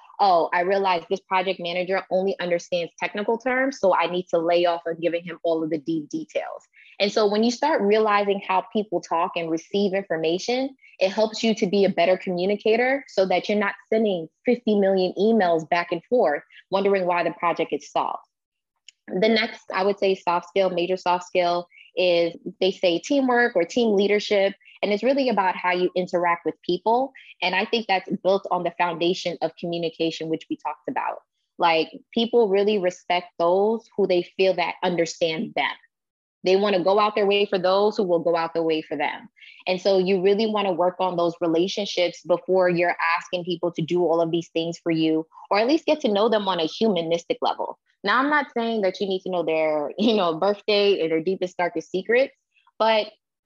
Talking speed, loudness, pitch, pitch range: 205 wpm, -23 LUFS, 185 Hz, 175-210 Hz